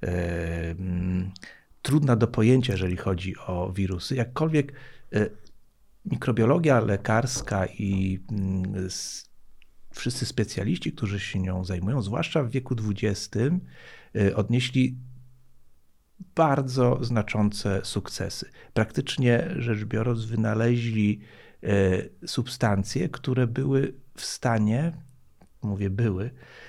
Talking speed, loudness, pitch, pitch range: 80 wpm, -26 LUFS, 115 Hz, 95-130 Hz